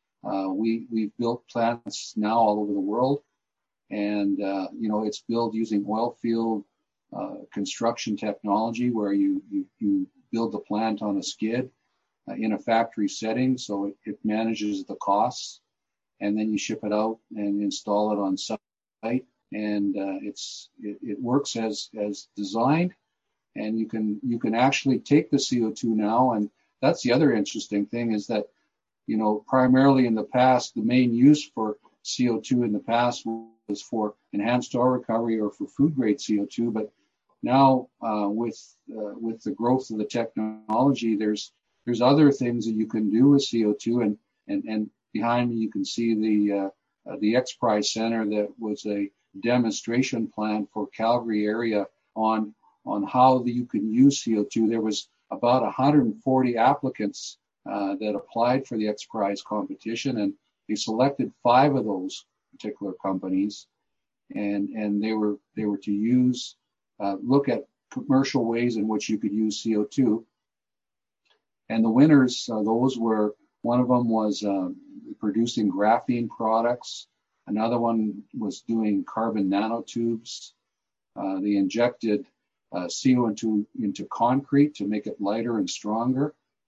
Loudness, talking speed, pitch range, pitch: -25 LUFS, 160 wpm, 105-125 Hz, 115 Hz